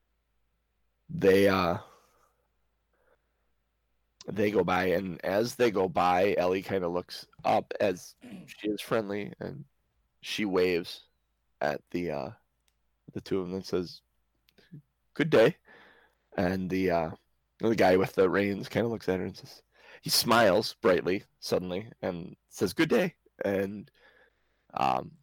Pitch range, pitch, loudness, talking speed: 65-100 Hz, 90 Hz, -28 LUFS, 140 wpm